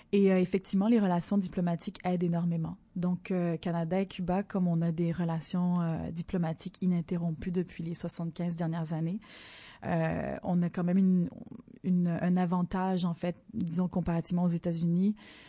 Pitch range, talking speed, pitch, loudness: 170-185 Hz, 160 wpm, 180 Hz, -31 LUFS